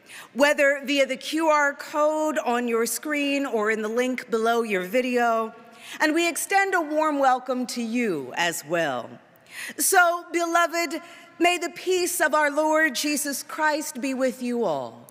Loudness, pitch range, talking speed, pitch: -23 LUFS, 240-315 Hz, 155 wpm, 285 Hz